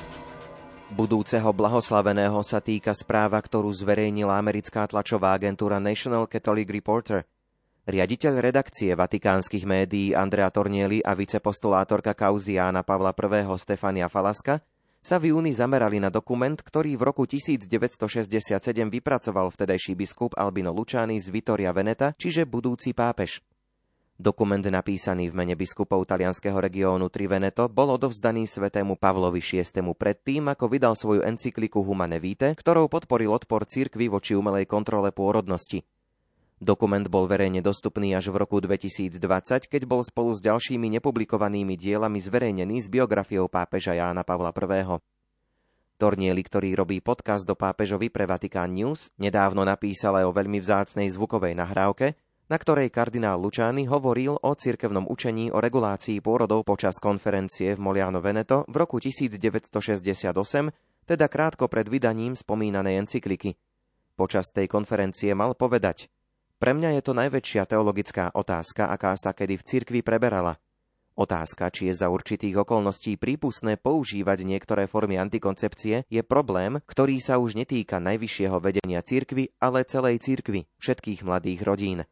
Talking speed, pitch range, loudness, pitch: 135 wpm, 95-120 Hz, -25 LUFS, 105 Hz